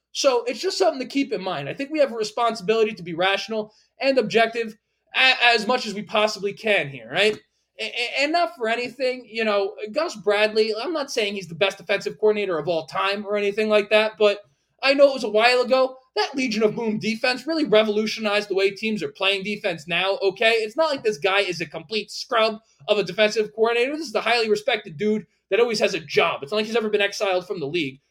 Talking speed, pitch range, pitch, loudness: 230 wpm, 200-240 Hz, 215 Hz, -22 LUFS